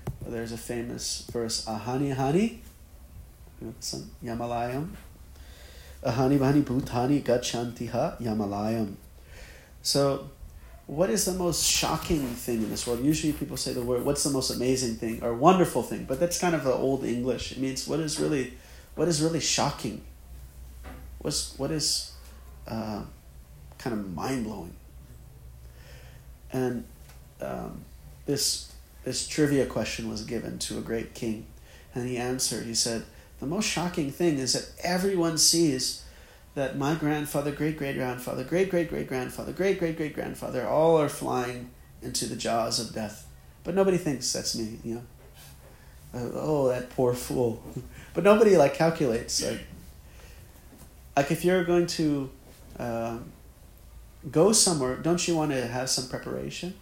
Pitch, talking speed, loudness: 125 Hz, 145 wpm, -27 LUFS